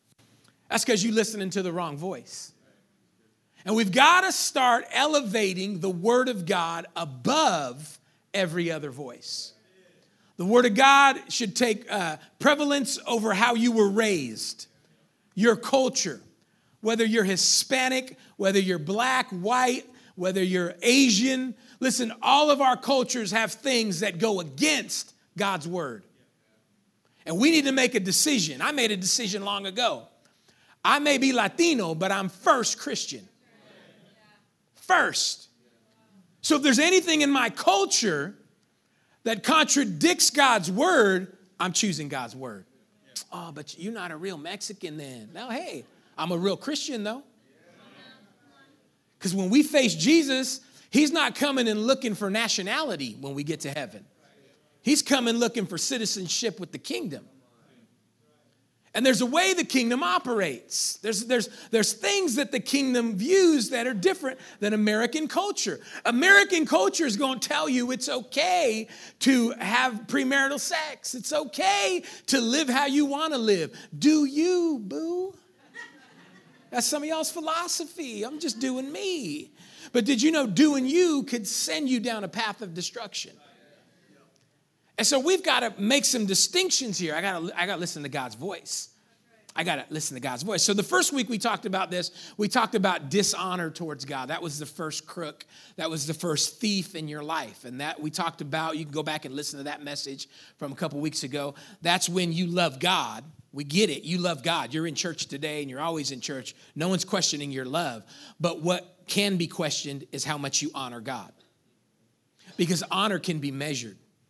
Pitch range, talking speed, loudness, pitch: 170-265 Hz, 165 wpm, -25 LUFS, 215 Hz